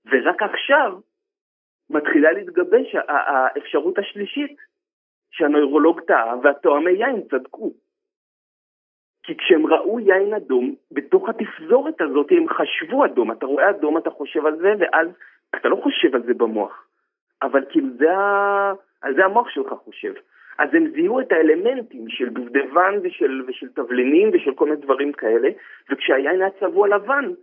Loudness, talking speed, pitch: -19 LUFS, 135 wpm, 285 Hz